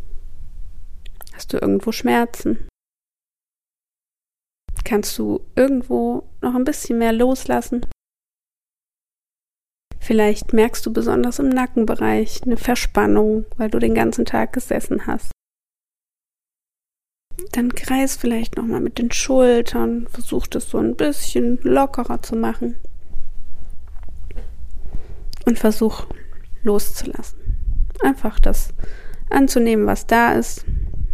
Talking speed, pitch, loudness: 100 wpm, 205 Hz, -20 LUFS